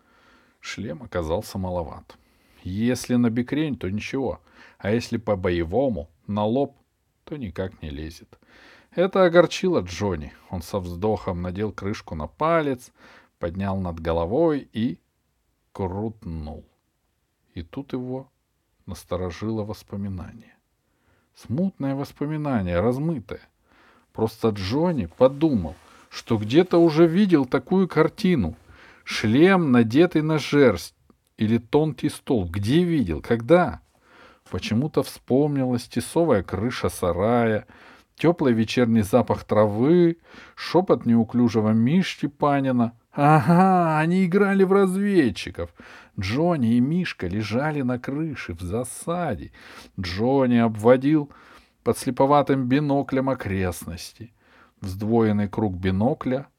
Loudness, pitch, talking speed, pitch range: -23 LUFS, 120 Hz, 100 wpm, 105-150 Hz